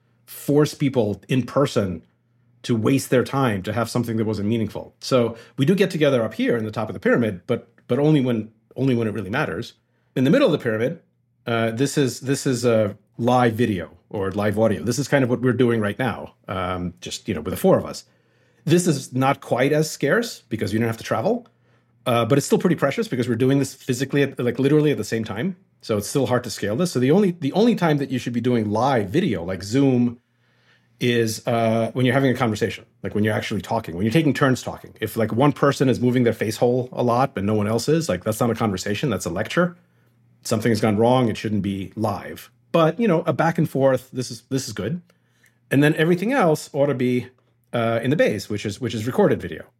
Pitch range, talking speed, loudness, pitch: 110-140 Hz, 240 wpm, -21 LUFS, 120 Hz